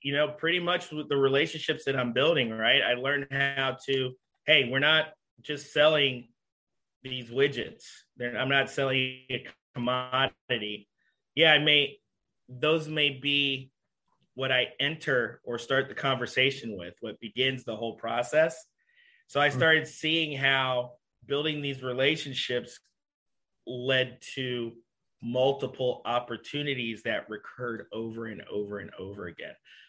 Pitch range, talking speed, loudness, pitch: 125-145 Hz, 135 wpm, -27 LUFS, 135 Hz